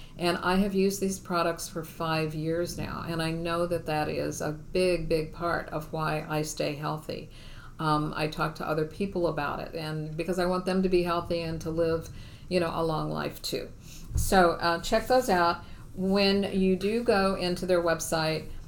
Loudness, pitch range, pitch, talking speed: -28 LUFS, 155-180 Hz, 170 Hz, 200 wpm